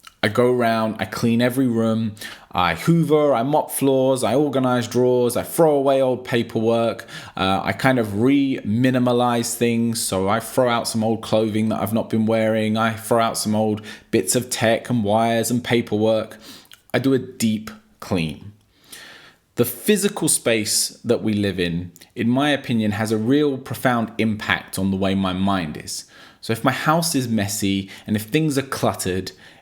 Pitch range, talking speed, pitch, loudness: 105-130 Hz, 180 wpm, 115 Hz, -20 LUFS